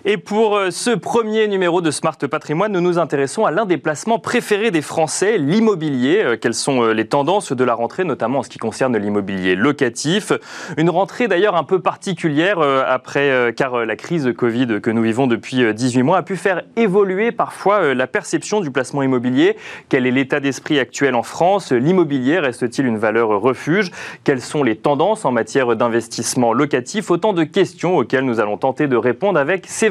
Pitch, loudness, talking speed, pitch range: 155 Hz, -17 LUFS, 185 wpm, 130-200 Hz